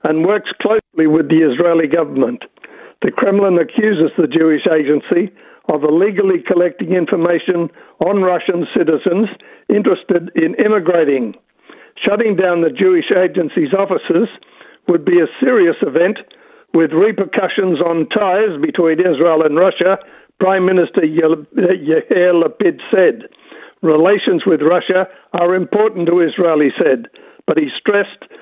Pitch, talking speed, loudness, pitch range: 180 Hz, 125 wpm, -14 LUFS, 165-210 Hz